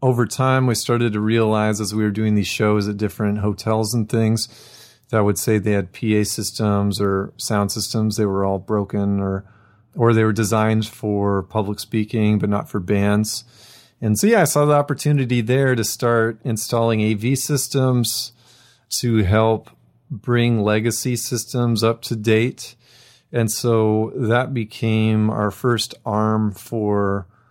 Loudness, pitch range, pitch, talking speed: -20 LUFS, 105-120 Hz, 110 Hz, 160 wpm